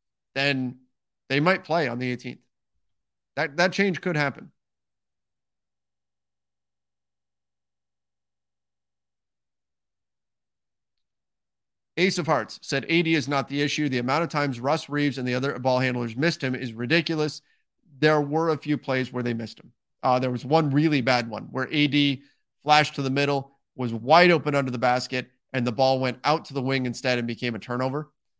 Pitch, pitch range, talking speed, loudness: 130 Hz, 120-150 Hz, 165 wpm, -24 LUFS